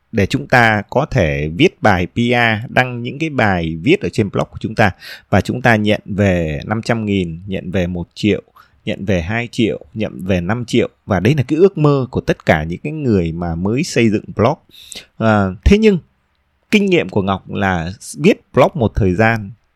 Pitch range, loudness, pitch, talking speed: 95-120 Hz, -16 LUFS, 105 Hz, 205 wpm